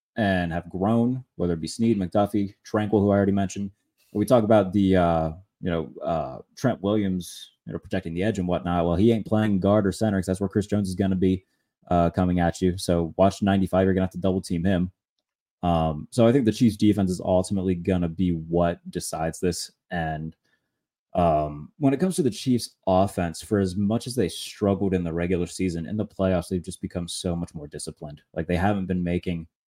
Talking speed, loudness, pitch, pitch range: 220 wpm, -24 LUFS, 95 Hz, 85-100 Hz